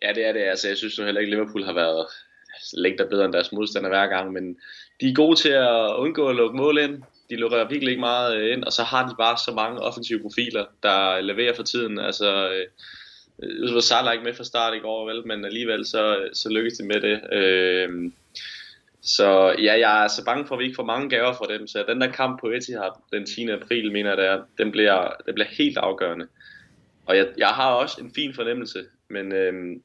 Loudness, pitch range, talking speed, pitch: -22 LUFS, 100-125 Hz, 225 wpm, 115 Hz